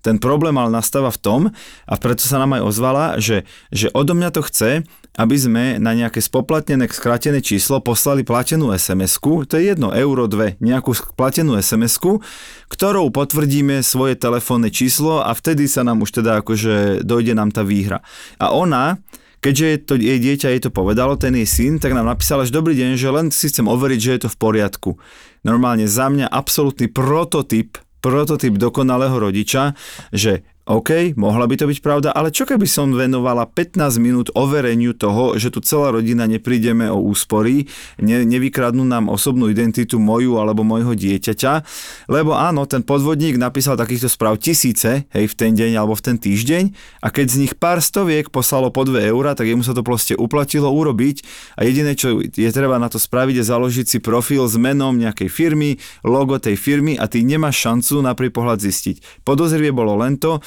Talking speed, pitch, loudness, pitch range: 185 wpm, 125 Hz, -16 LUFS, 115-145 Hz